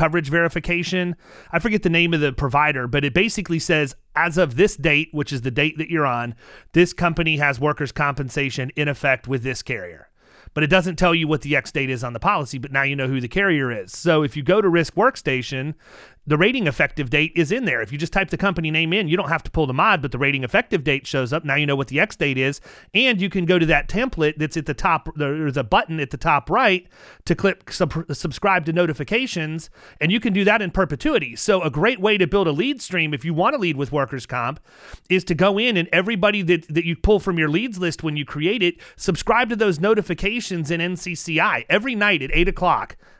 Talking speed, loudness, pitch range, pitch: 245 wpm, -20 LUFS, 145-185 Hz, 165 Hz